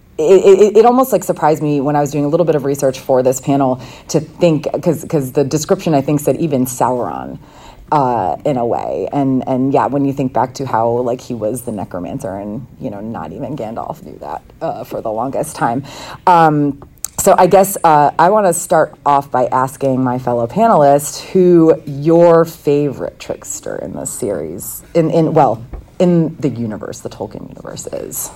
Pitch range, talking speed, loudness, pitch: 130-170 Hz, 195 wpm, -14 LUFS, 145 Hz